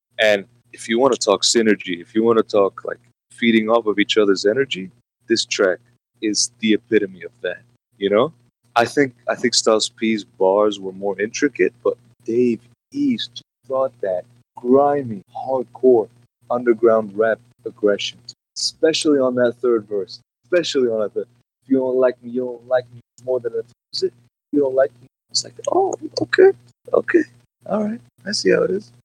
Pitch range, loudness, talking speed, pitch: 110-135 Hz, -19 LUFS, 175 wpm, 120 Hz